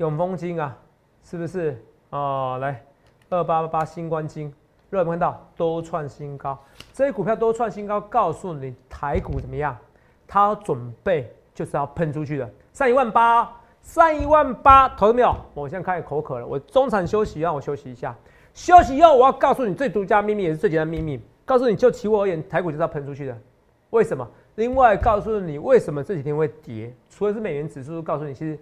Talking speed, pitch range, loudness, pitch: 315 characters per minute, 145-215 Hz, -21 LUFS, 165 Hz